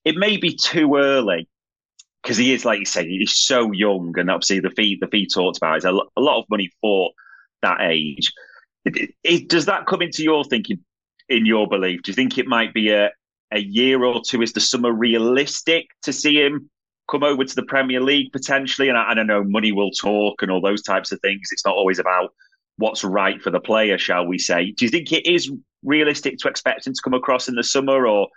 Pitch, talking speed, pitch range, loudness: 125 Hz, 235 wpm, 105-145 Hz, -19 LUFS